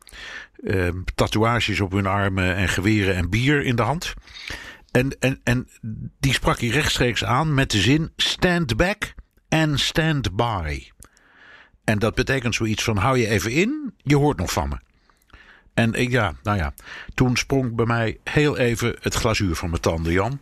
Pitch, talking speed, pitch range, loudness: 115 Hz, 175 wpm, 100-135 Hz, -21 LUFS